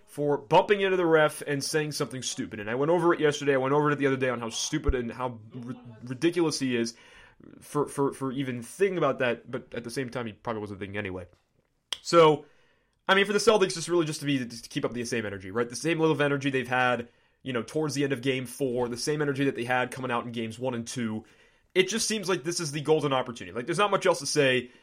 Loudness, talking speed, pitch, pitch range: -27 LUFS, 270 wpm, 135 Hz, 120-155 Hz